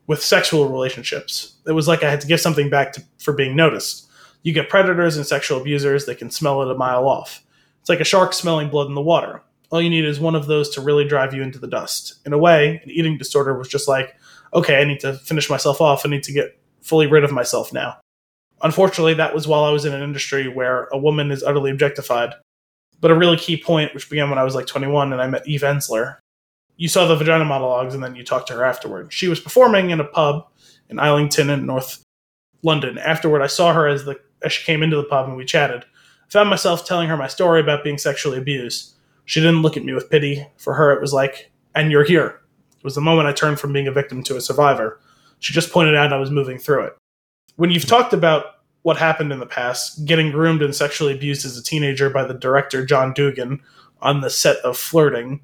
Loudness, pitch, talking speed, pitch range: -18 LUFS, 145 Hz, 240 wpm, 135-160 Hz